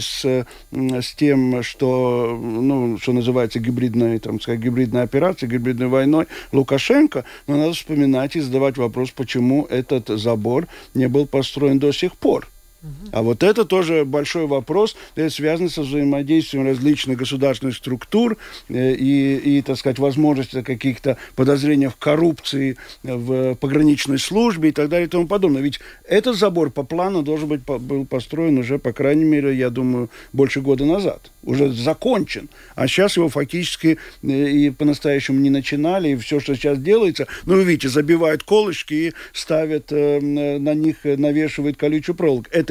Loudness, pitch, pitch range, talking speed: -19 LUFS, 140 Hz, 130-155 Hz, 145 wpm